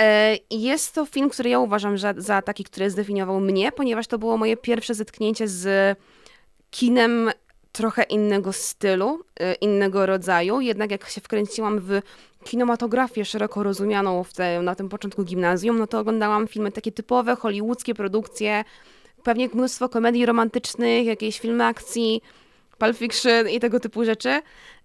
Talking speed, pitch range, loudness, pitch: 140 wpm, 200-235 Hz, -23 LUFS, 220 Hz